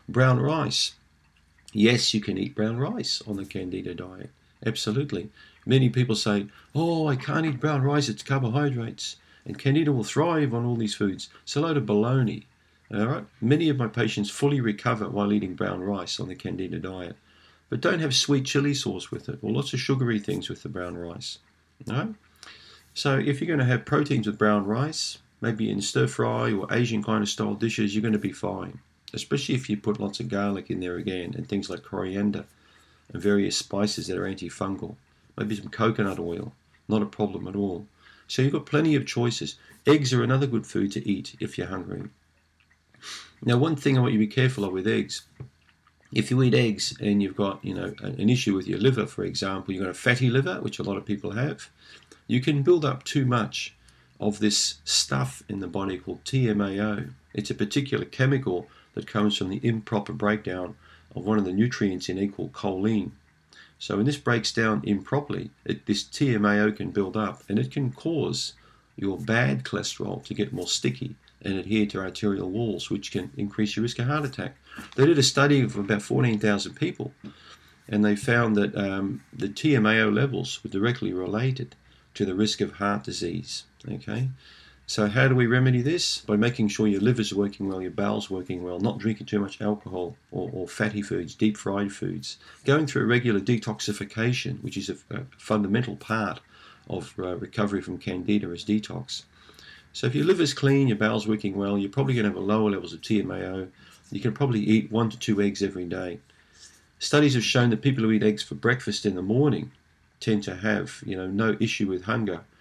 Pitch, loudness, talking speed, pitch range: 105 Hz, -26 LUFS, 200 wpm, 100-125 Hz